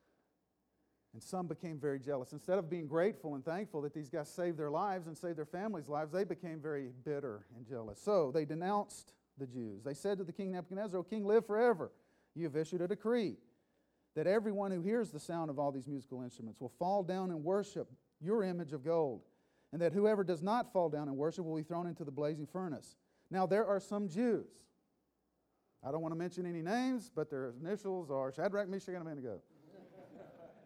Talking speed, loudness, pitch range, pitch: 205 wpm, -38 LUFS, 150-195 Hz, 170 Hz